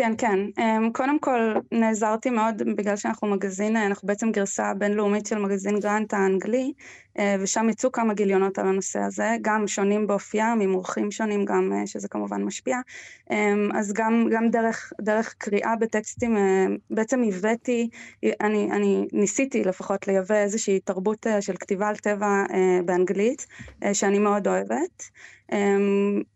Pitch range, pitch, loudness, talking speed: 195-225 Hz, 205 Hz, -24 LUFS, 130 wpm